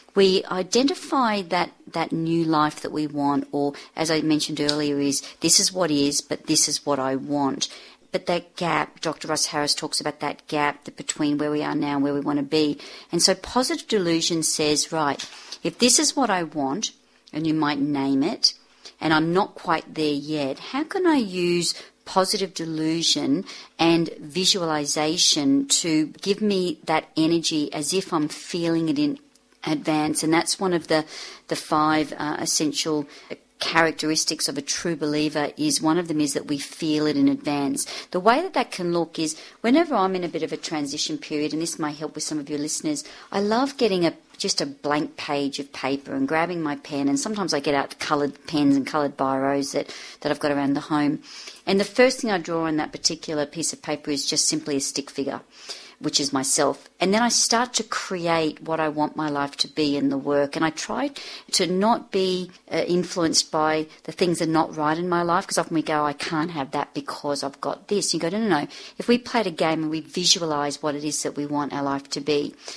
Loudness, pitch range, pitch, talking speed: -23 LUFS, 150-185 Hz, 155 Hz, 215 wpm